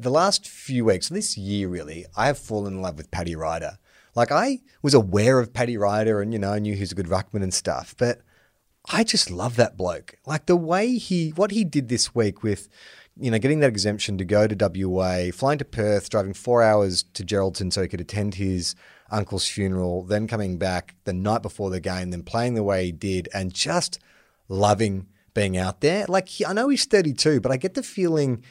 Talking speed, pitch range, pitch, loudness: 220 wpm, 95-135 Hz, 105 Hz, -23 LUFS